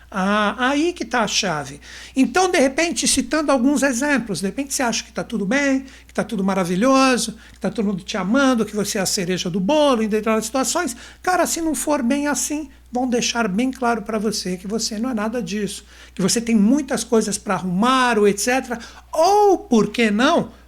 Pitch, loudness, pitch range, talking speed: 235 Hz, -19 LUFS, 210-275 Hz, 205 wpm